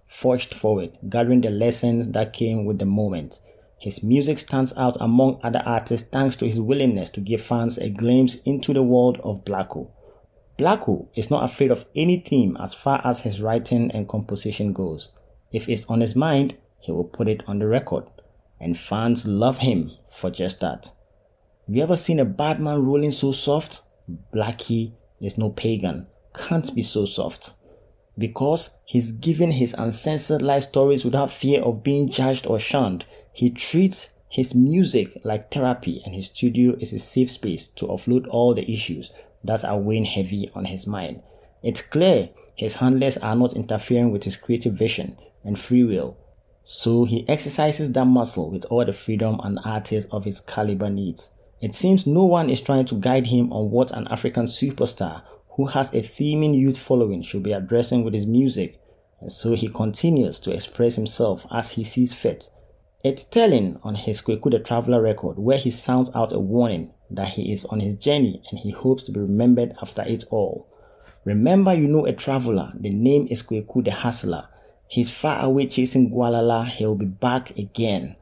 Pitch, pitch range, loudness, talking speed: 120 Hz, 105-130 Hz, -21 LUFS, 180 wpm